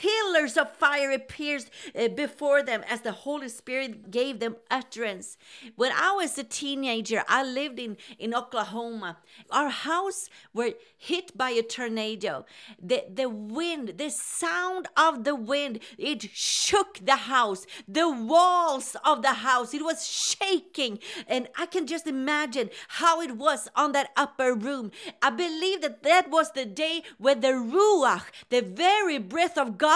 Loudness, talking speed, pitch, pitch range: -26 LUFS, 155 wpm, 280 Hz, 240-325 Hz